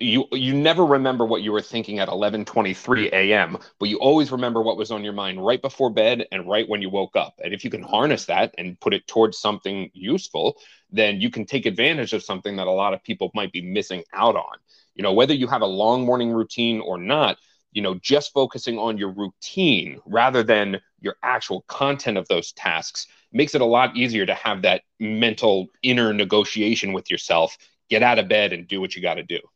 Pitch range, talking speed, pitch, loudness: 100-125 Hz, 220 wpm, 110 Hz, -21 LUFS